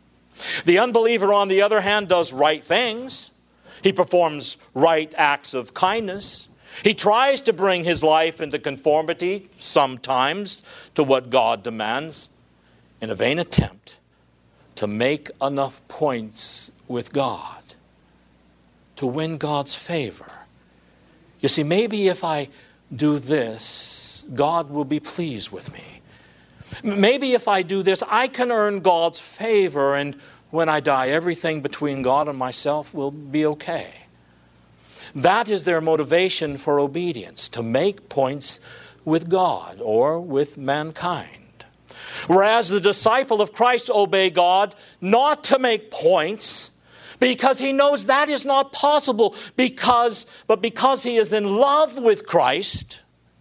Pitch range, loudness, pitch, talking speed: 135-210 Hz, -21 LUFS, 165 Hz, 135 wpm